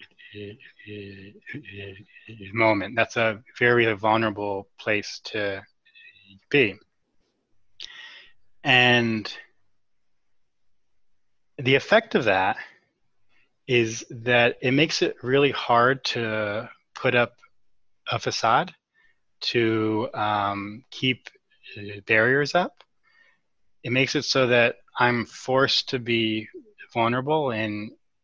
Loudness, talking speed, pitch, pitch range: -23 LUFS, 85 wpm, 120 Hz, 110-135 Hz